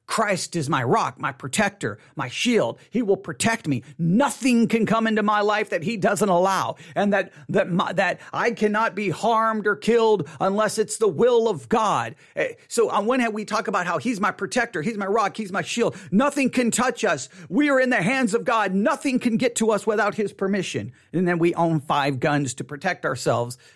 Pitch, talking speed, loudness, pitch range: 210 Hz, 210 wpm, -22 LUFS, 175-230 Hz